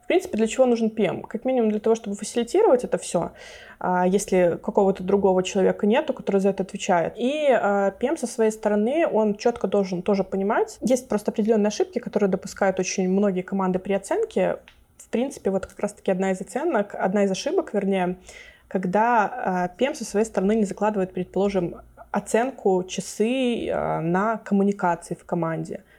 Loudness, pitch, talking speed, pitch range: -23 LUFS, 205 Hz, 160 wpm, 190-225 Hz